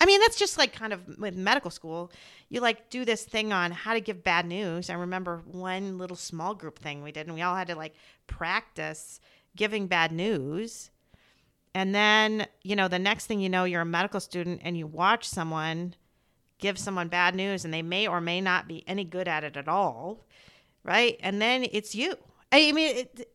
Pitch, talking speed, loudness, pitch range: 185 Hz, 210 wpm, -27 LUFS, 175-215 Hz